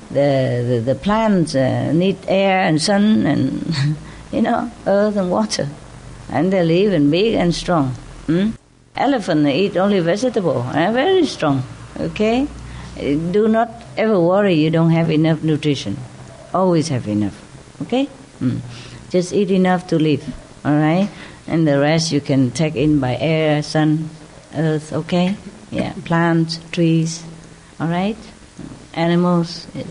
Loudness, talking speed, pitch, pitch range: -18 LUFS, 145 wpm, 165 Hz, 145-190 Hz